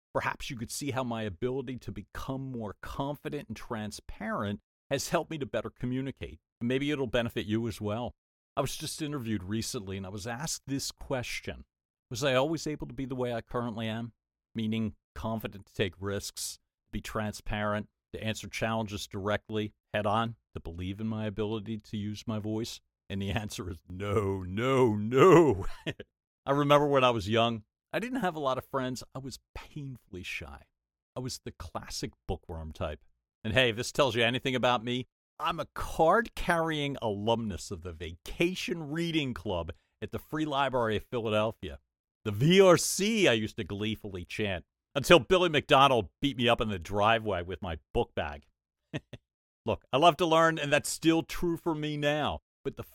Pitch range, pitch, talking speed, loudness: 100-135 Hz, 115 Hz, 180 wpm, -30 LUFS